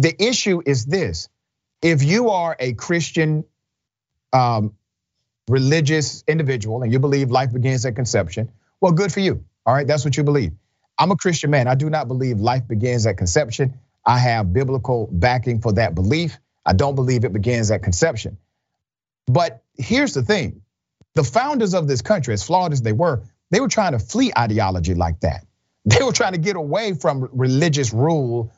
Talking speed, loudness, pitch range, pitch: 180 wpm, -19 LUFS, 115-160 Hz, 130 Hz